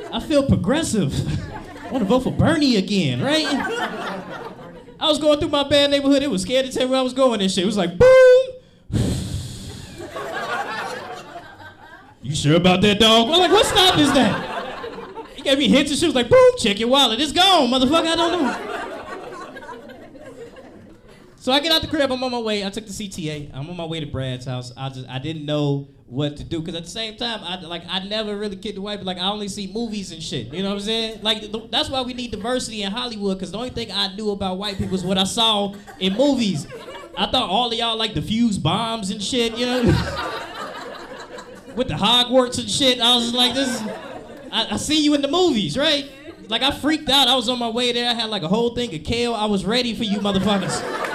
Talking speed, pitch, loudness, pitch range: 235 wpm, 225 Hz, -19 LUFS, 195-265 Hz